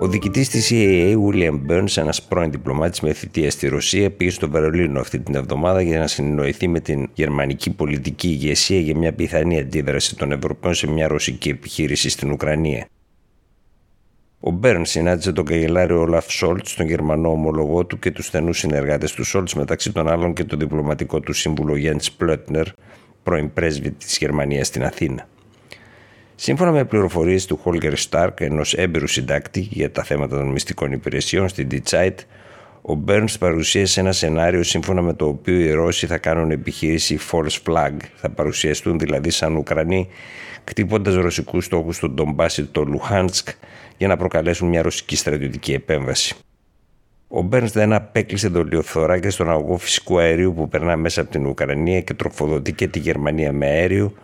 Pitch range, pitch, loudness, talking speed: 75-95 Hz, 85 Hz, -19 LUFS, 165 wpm